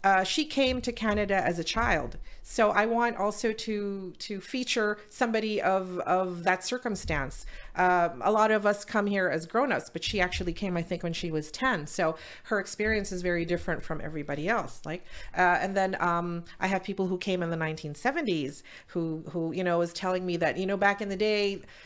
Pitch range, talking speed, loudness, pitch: 175-210 Hz, 205 wpm, -29 LUFS, 190 Hz